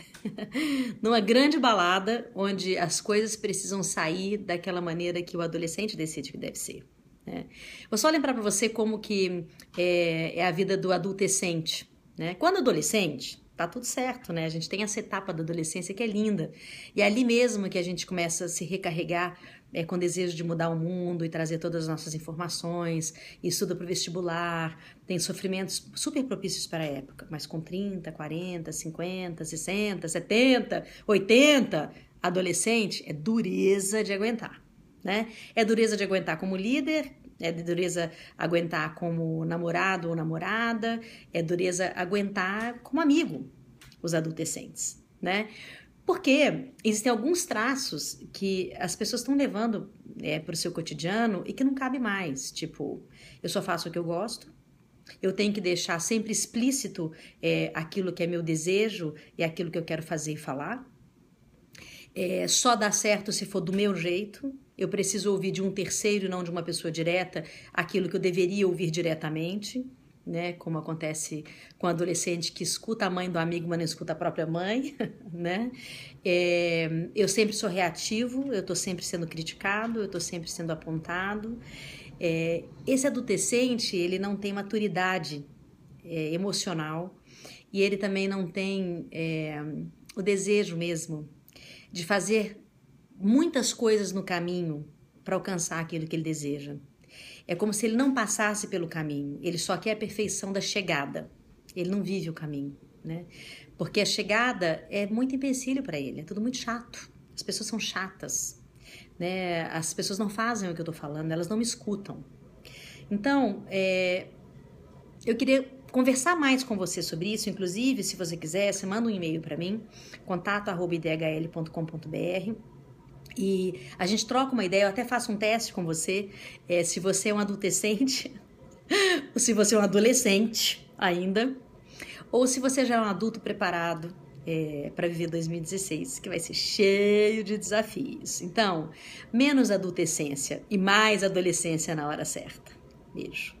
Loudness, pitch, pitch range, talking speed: -28 LUFS, 185 Hz, 165-215 Hz, 160 wpm